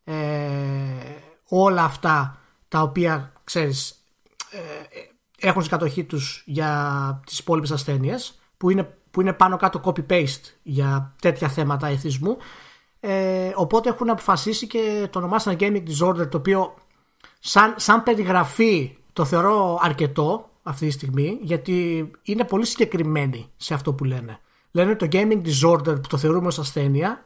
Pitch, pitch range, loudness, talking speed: 170 Hz, 150-195 Hz, -22 LUFS, 140 wpm